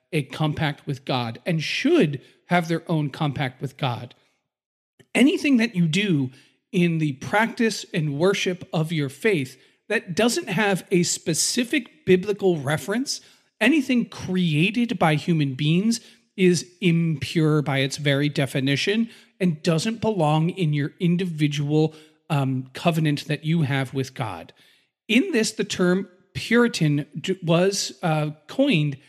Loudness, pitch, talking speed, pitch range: -23 LUFS, 165 Hz, 130 wpm, 145-200 Hz